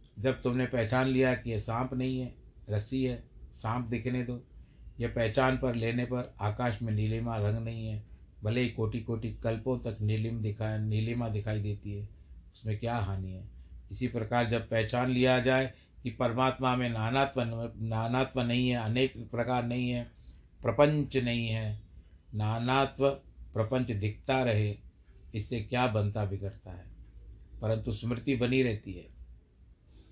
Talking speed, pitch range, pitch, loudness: 150 wpm, 105-125 Hz, 115 Hz, -32 LUFS